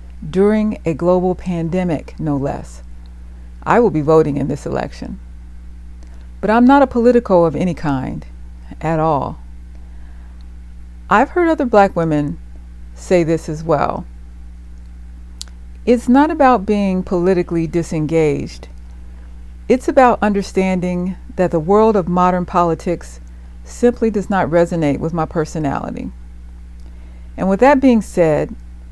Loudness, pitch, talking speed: -16 LUFS, 155 Hz, 120 wpm